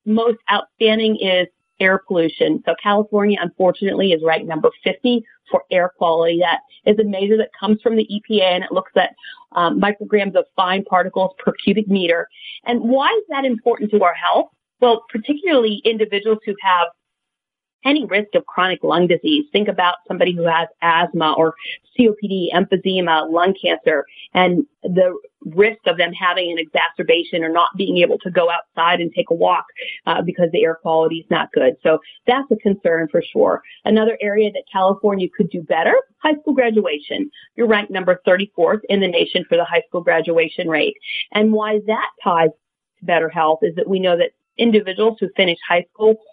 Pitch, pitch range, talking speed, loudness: 195 Hz, 175-225 Hz, 180 wpm, -17 LUFS